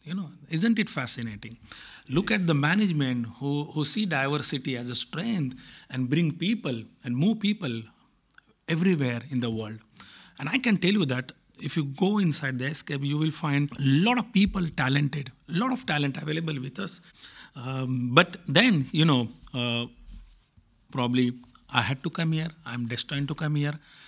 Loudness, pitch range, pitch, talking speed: -27 LUFS, 125-175 Hz, 145 Hz, 175 wpm